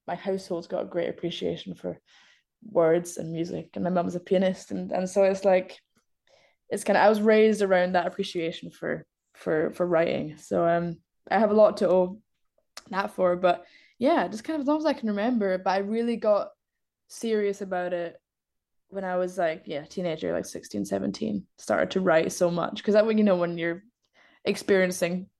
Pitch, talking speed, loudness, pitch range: 185 Hz, 195 wpm, -26 LUFS, 170-205 Hz